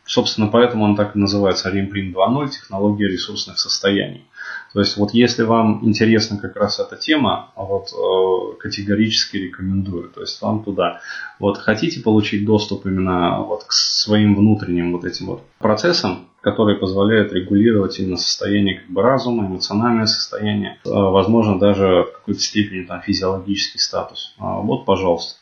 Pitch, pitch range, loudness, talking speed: 100 Hz, 95-110 Hz, -18 LUFS, 145 wpm